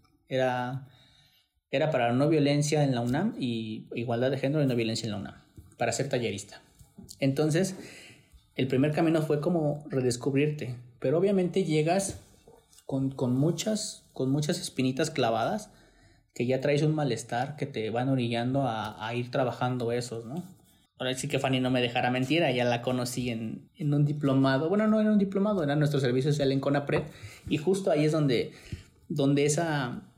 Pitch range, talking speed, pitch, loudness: 125-150 Hz, 170 wpm, 135 Hz, -28 LUFS